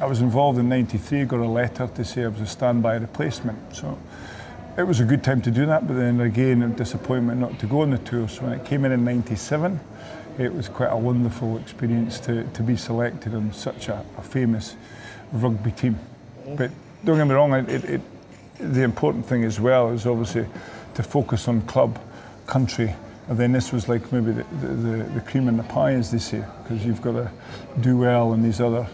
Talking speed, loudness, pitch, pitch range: 215 wpm, -23 LUFS, 120 Hz, 115-125 Hz